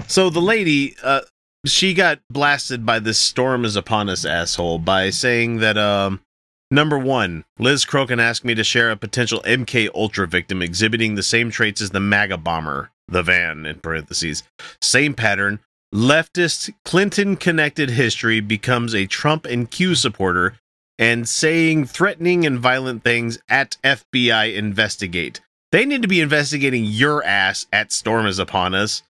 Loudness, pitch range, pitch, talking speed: -18 LUFS, 100-140 Hz, 115 Hz, 155 wpm